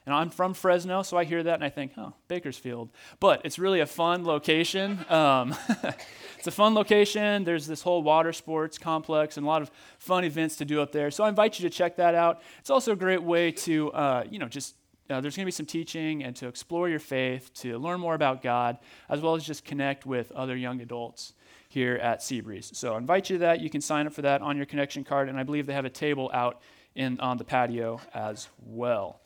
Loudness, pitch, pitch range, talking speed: -28 LUFS, 150 Hz, 130-170 Hz, 240 wpm